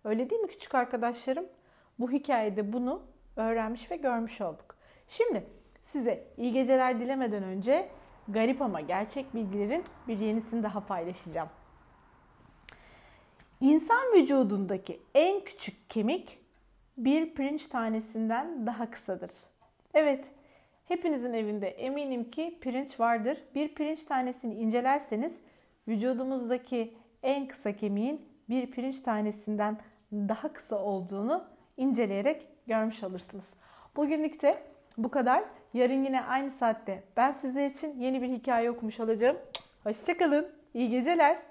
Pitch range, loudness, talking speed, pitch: 220-285 Hz, -31 LUFS, 115 wpm, 250 Hz